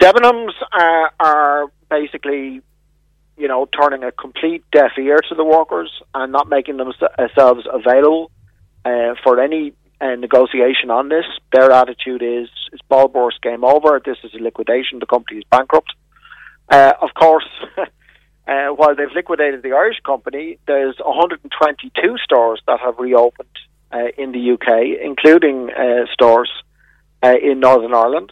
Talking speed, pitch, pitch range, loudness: 145 wpm, 135 Hz, 120-150 Hz, -14 LUFS